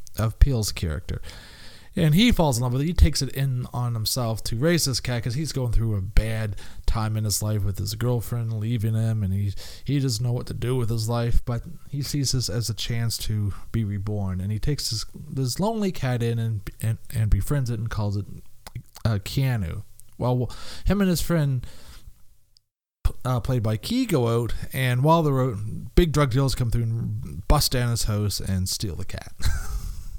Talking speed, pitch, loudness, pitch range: 205 wpm, 115 Hz, -25 LUFS, 105-130 Hz